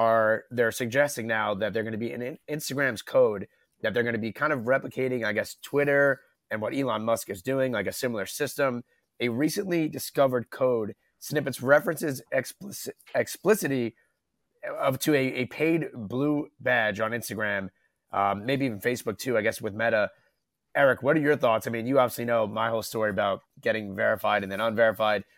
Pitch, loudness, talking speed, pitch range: 125 Hz, -27 LUFS, 185 wpm, 110-140 Hz